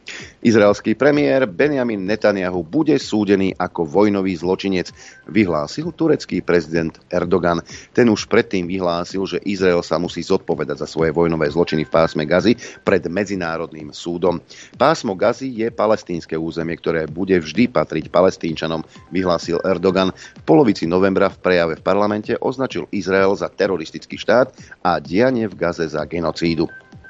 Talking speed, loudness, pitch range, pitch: 135 wpm, -19 LUFS, 85-100 Hz, 90 Hz